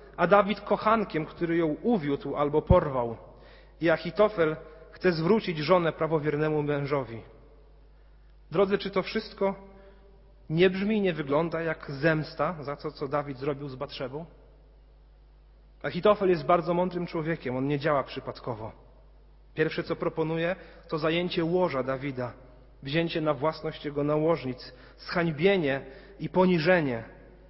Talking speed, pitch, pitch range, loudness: 125 wpm, 160 Hz, 145-180 Hz, -28 LUFS